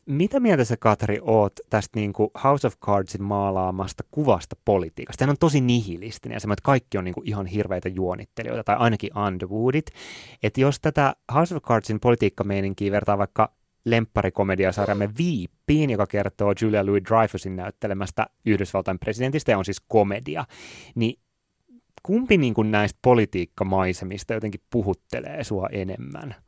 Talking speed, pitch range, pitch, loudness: 140 wpm, 100-120 Hz, 105 Hz, -24 LUFS